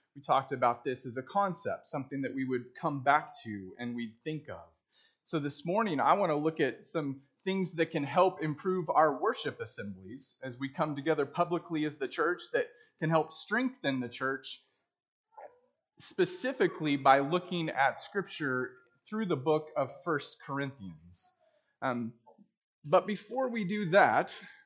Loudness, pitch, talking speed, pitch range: -32 LUFS, 155 Hz, 160 wpm, 135-200 Hz